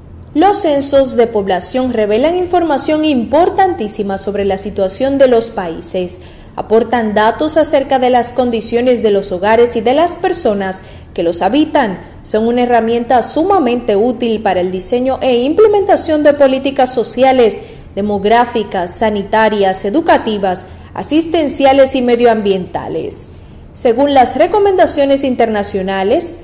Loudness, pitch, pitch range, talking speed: -12 LUFS, 245 Hz, 210-285 Hz, 120 wpm